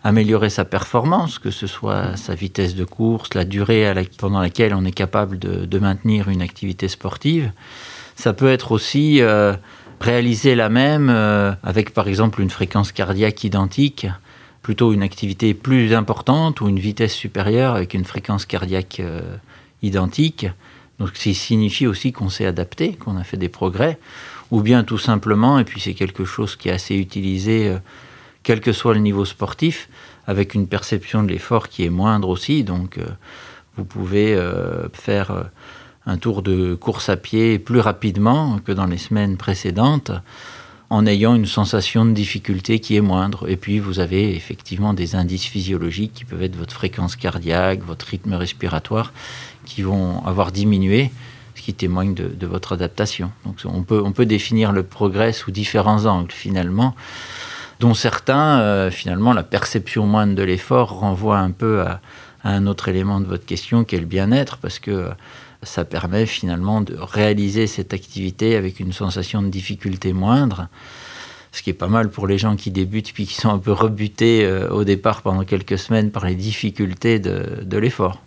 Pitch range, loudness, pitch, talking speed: 95-115 Hz, -19 LUFS, 105 Hz, 175 wpm